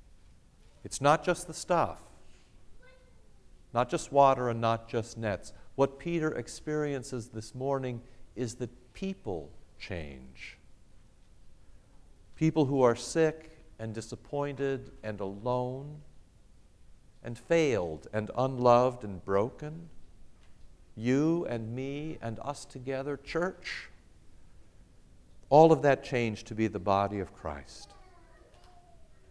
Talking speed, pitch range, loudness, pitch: 105 wpm, 100-140 Hz, -30 LUFS, 120 Hz